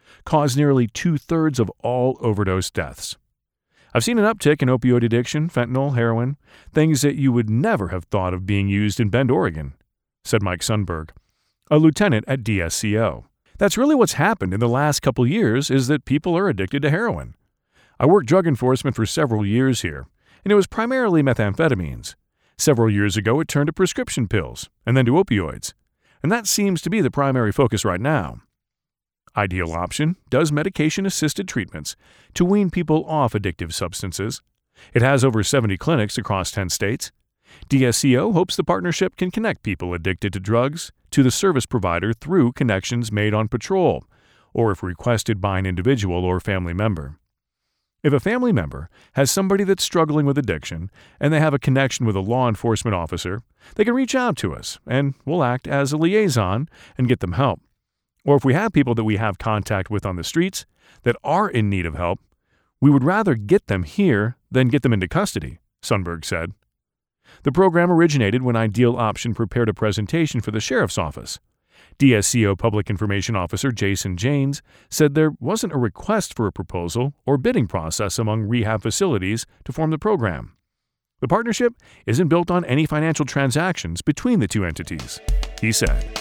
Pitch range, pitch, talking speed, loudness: 105-150 Hz, 120 Hz, 175 wpm, -20 LUFS